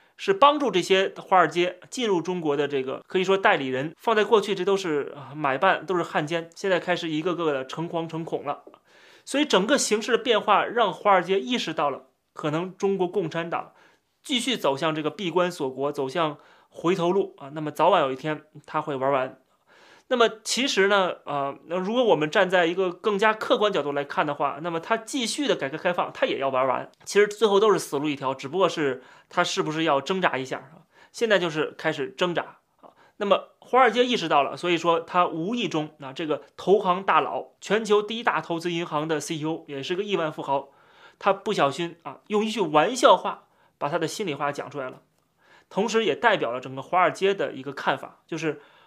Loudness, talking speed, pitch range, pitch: -24 LUFS, 310 characters per minute, 150-205 Hz, 175 Hz